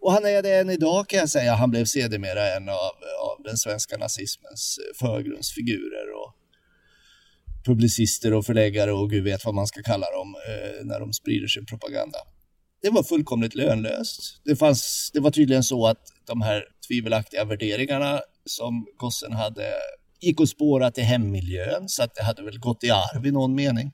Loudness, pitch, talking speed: -24 LUFS, 125 Hz, 175 wpm